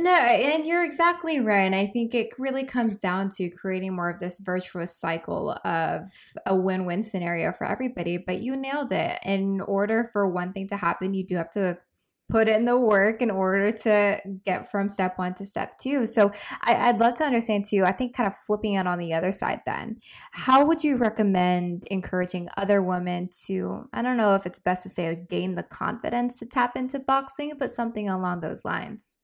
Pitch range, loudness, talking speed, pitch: 185-240 Hz, -25 LUFS, 205 wpm, 200 Hz